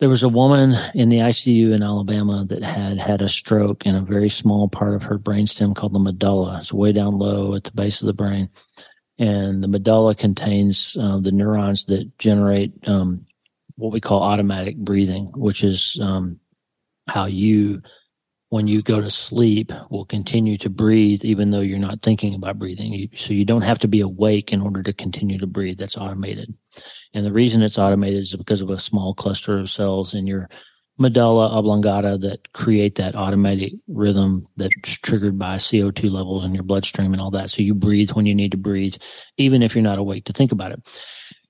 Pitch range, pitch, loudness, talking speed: 100-105 Hz, 100 Hz, -19 LUFS, 200 wpm